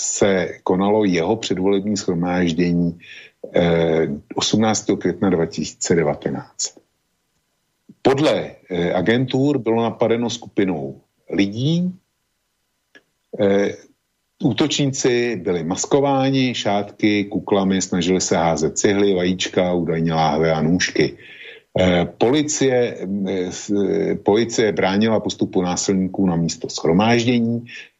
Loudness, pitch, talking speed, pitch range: -19 LUFS, 100 Hz, 75 wpm, 90-115 Hz